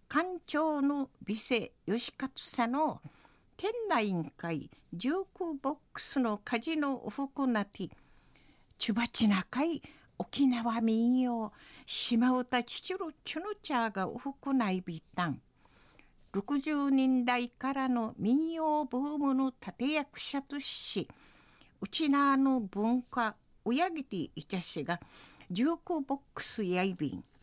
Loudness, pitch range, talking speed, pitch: -33 LUFS, 215-285 Hz, 190 characters per minute, 255 Hz